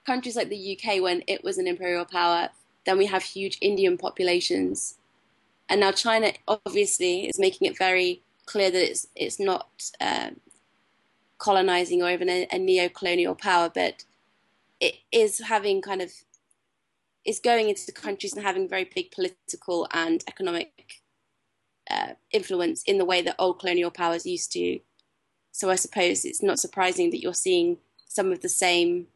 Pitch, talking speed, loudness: 205 Hz, 165 wpm, -25 LUFS